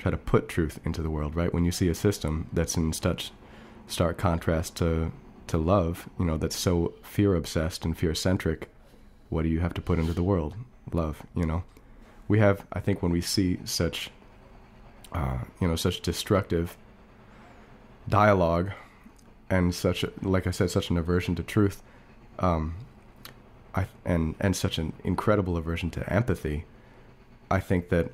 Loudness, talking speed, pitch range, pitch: -28 LUFS, 170 wpm, 85-100 Hz, 90 Hz